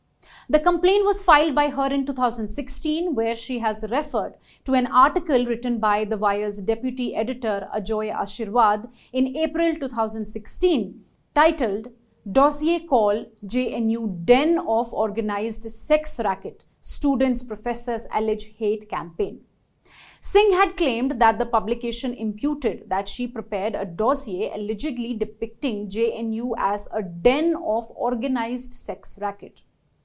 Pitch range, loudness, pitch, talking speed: 215-270 Hz, -23 LUFS, 235 Hz, 125 wpm